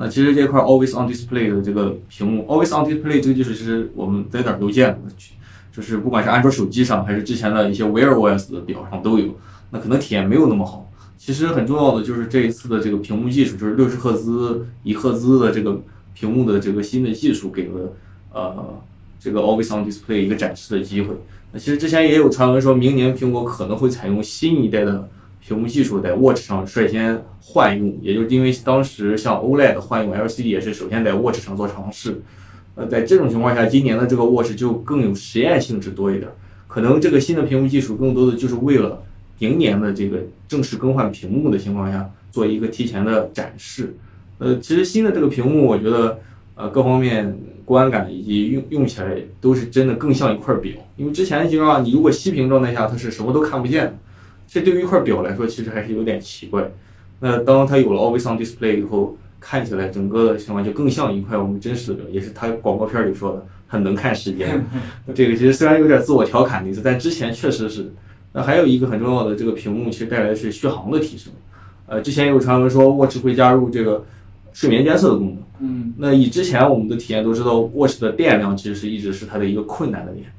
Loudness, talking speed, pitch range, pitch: -18 LUFS, 390 characters per minute, 100-130 Hz, 110 Hz